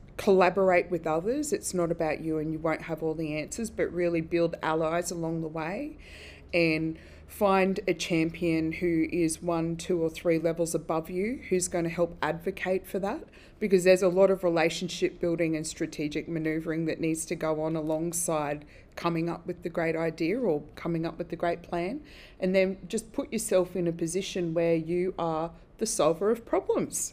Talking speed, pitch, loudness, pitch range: 190 wpm, 170 Hz, -29 LUFS, 160-185 Hz